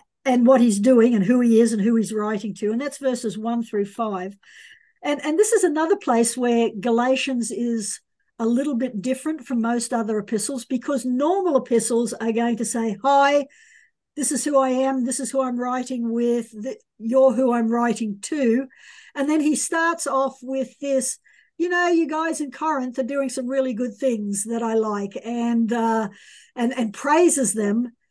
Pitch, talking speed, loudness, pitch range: 250 Hz, 190 wpm, -22 LUFS, 230-275 Hz